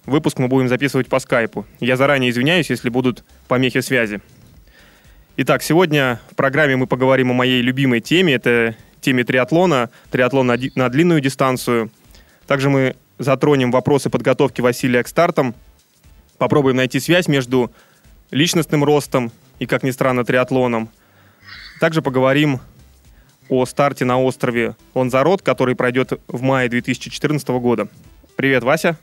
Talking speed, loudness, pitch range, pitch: 130 wpm, -17 LUFS, 125-140 Hz, 130 Hz